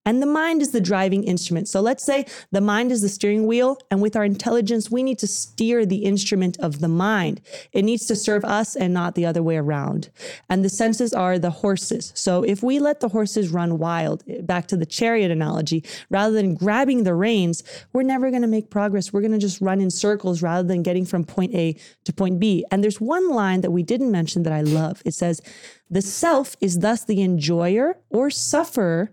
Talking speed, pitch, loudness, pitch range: 220 wpm, 200 Hz, -21 LUFS, 180-230 Hz